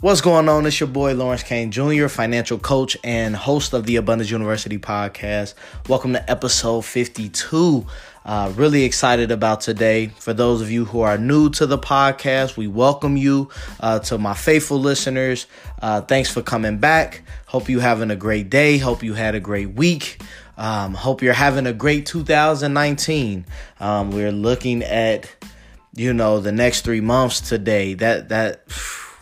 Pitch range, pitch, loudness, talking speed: 110-140 Hz, 120 Hz, -19 LUFS, 170 wpm